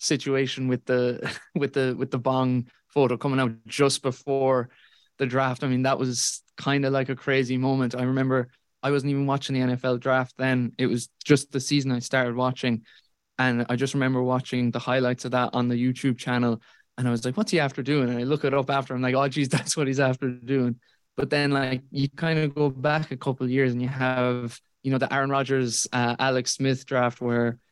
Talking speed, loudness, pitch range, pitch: 225 wpm, -25 LUFS, 125-140 Hz, 130 Hz